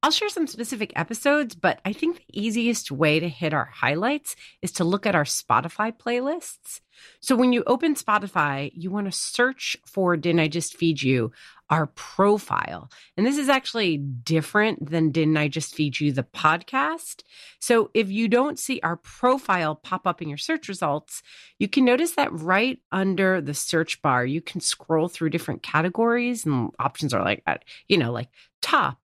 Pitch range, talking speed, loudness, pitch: 155-235 Hz, 180 wpm, -24 LUFS, 185 Hz